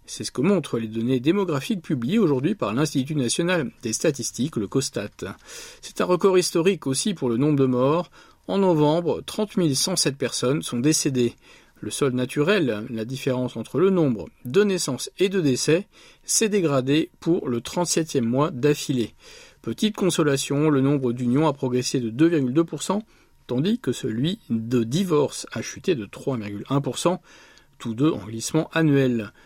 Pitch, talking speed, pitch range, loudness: 145 Hz, 155 wpm, 125-175 Hz, -23 LUFS